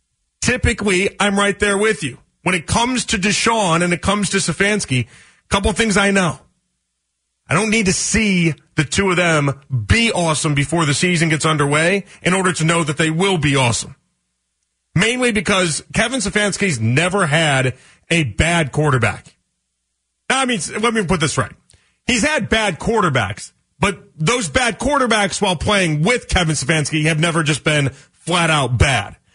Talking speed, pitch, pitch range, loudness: 170 wpm, 170 Hz, 145-200 Hz, -17 LUFS